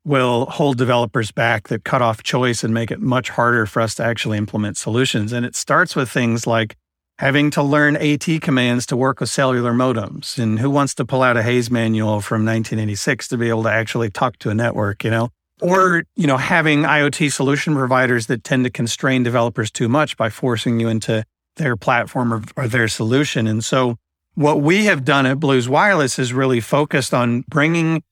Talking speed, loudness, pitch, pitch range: 205 wpm, -18 LUFS, 125 Hz, 115-140 Hz